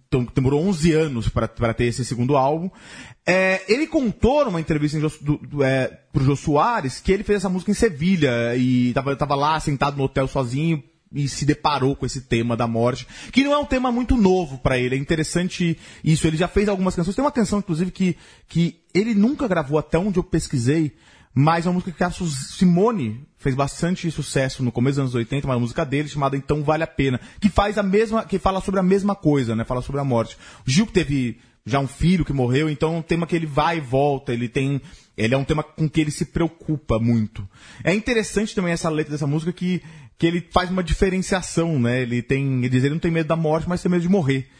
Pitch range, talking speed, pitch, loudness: 135-180 Hz, 225 wpm, 155 Hz, -21 LUFS